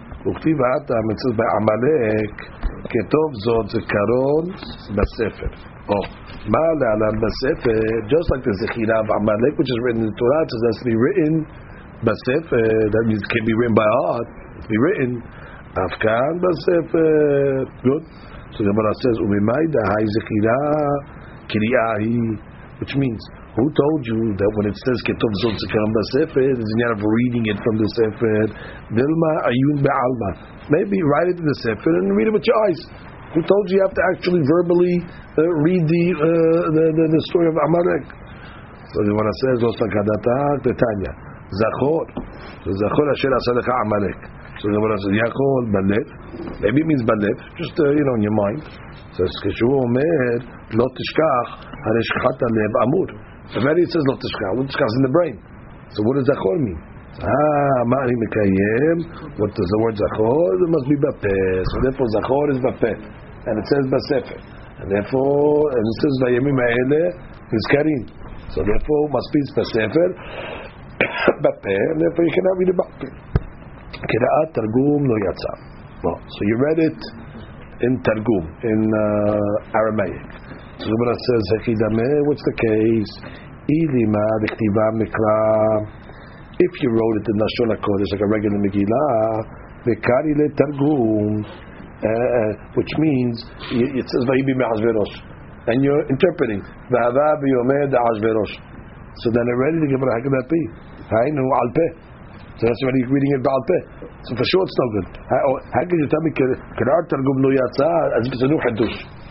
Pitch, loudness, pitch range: 120 Hz, -19 LUFS, 110-145 Hz